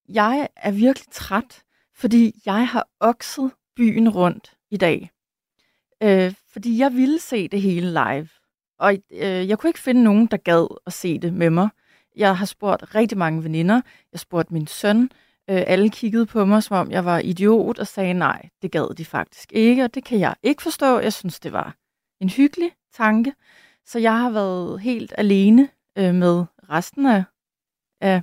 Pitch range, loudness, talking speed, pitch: 180-235 Hz, -20 LUFS, 185 wpm, 210 Hz